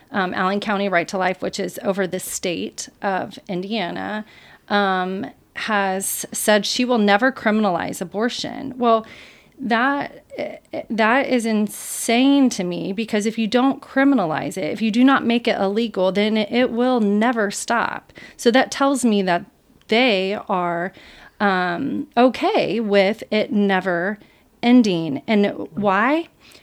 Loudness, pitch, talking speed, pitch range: -20 LUFS, 220 Hz, 135 wpm, 195-250 Hz